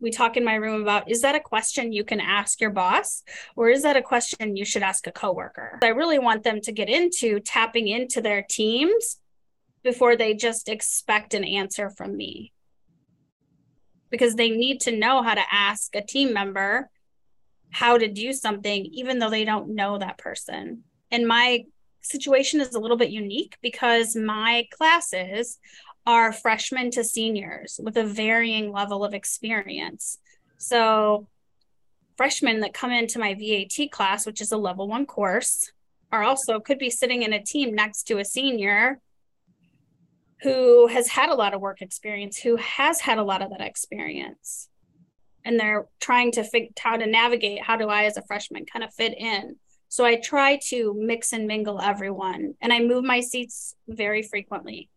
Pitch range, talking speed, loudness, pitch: 210-245 Hz, 175 wpm, -23 LUFS, 230 Hz